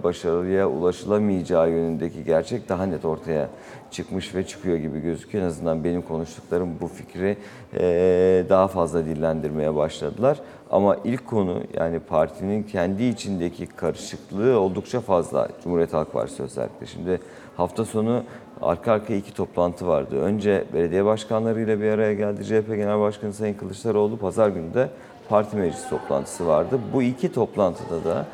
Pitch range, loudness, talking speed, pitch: 85-105 Hz, -24 LUFS, 140 wpm, 95 Hz